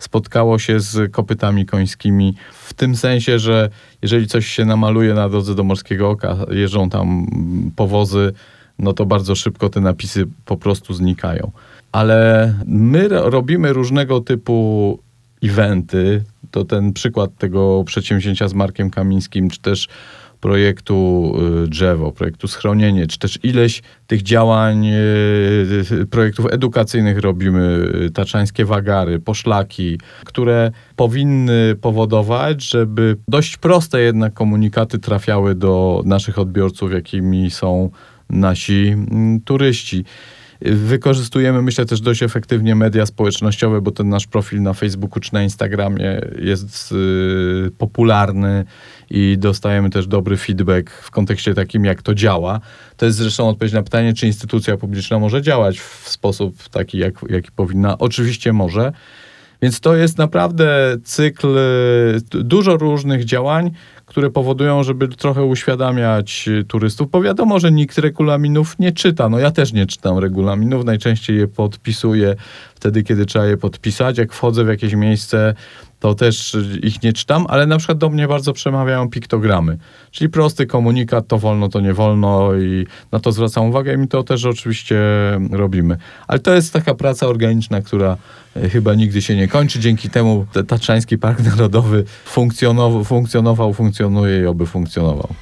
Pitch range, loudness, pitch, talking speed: 100-120 Hz, -16 LUFS, 110 Hz, 135 wpm